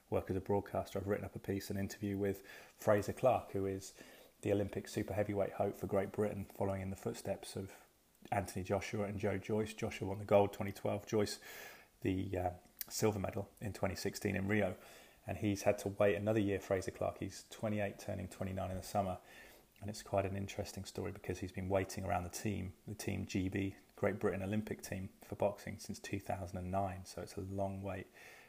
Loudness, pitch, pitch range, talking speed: -39 LUFS, 100 Hz, 95-105 Hz, 195 wpm